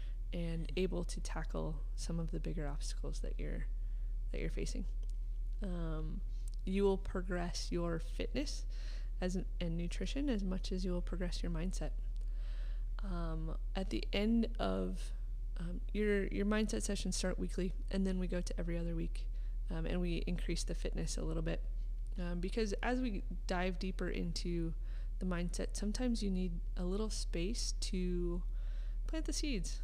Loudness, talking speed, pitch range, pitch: -40 LUFS, 160 wpm, 120-185 Hz, 170 Hz